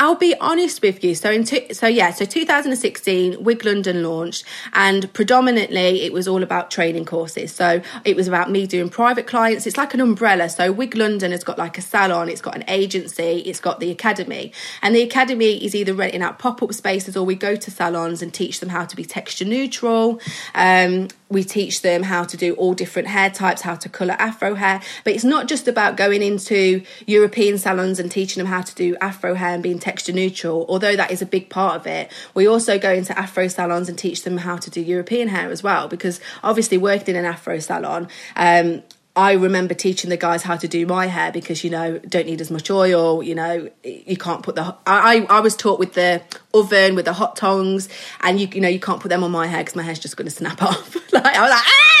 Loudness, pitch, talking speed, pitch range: -18 LUFS, 185 Hz, 235 wpm, 175-205 Hz